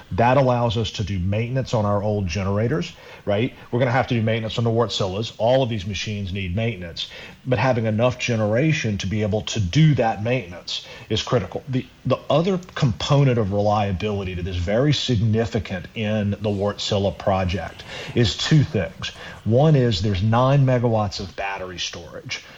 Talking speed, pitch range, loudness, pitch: 175 wpm, 100-125 Hz, -22 LUFS, 110 Hz